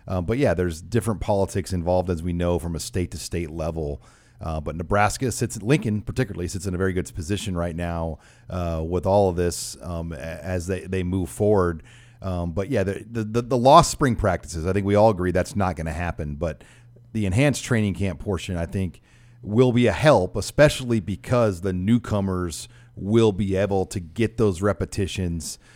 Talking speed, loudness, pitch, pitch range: 195 wpm, -23 LUFS, 95 Hz, 90-115 Hz